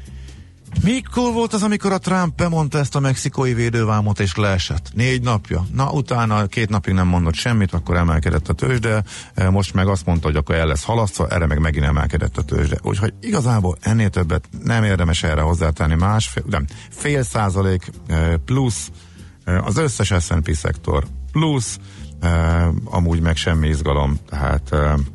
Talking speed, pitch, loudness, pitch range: 155 wpm, 95 Hz, -19 LUFS, 80-115 Hz